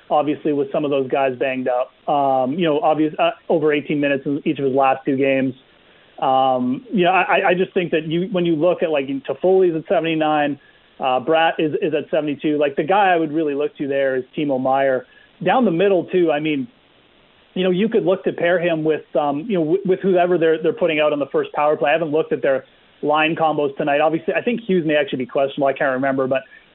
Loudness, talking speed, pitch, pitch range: -19 LUFS, 245 wpm, 150 Hz, 135-170 Hz